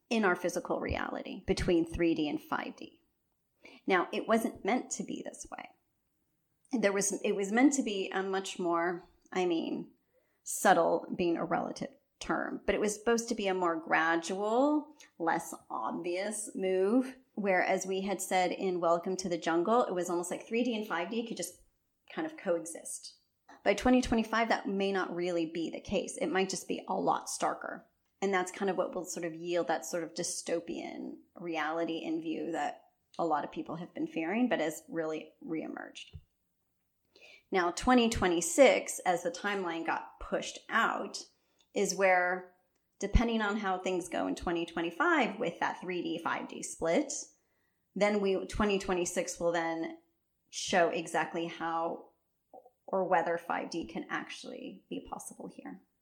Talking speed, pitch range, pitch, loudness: 160 wpm, 170-240 Hz, 190 Hz, -32 LUFS